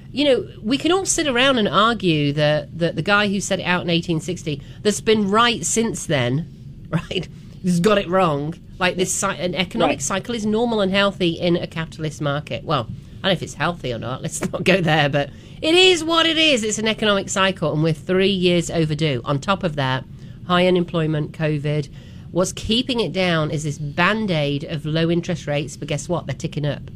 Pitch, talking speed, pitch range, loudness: 175 Hz, 210 wpm, 150-200 Hz, -20 LUFS